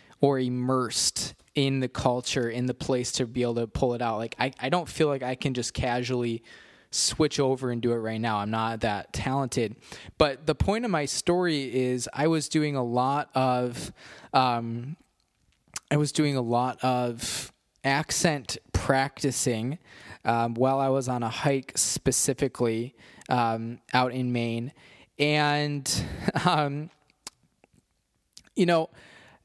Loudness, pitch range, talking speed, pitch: -27 LUFS, 120-145 Hz, 150 wpm, 130 Hz